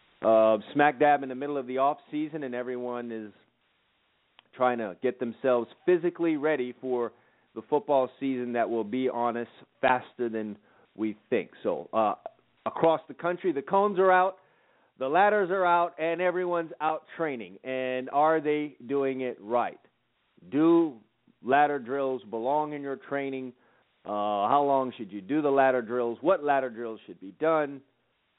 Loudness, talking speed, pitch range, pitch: -28 LUFS, 165 wpm, 120-155 Hz, 135 Hz